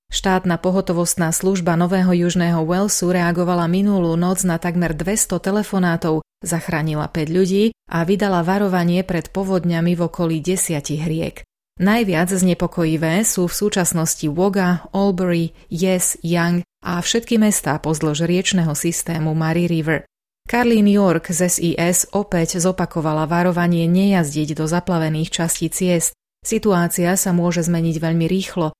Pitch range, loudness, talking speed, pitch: 165-185 Hz, -18 LUFS, 125 wpm, 175 Hz